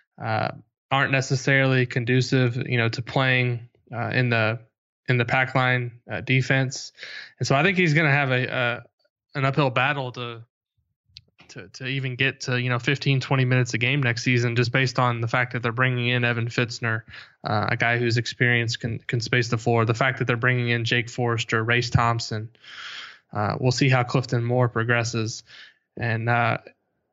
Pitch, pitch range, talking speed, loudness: 125 Hz, 120-130 Hz, 190 wpm, -23 LUFS